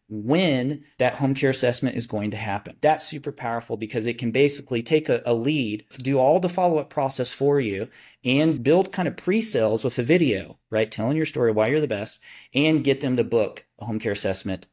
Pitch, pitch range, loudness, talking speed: 130 Hz, 115-150 Hz, -23 LUFS, 220 wpm